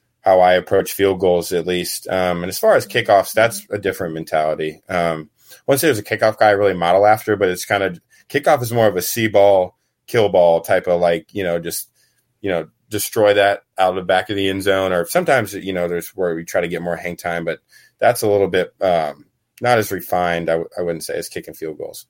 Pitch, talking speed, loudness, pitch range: 90 Hz, 240 wpm, -18 LUFS, 85-100 Hz